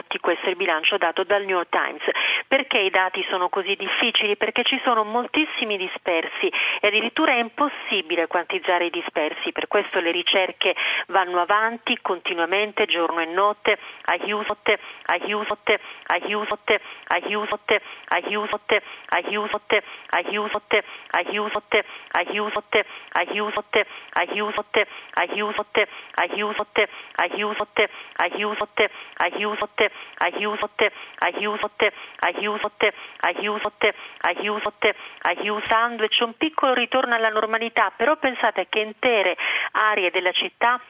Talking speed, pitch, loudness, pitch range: 110 wpm, 210 Hz, -22 LUFS, 205-220 Hz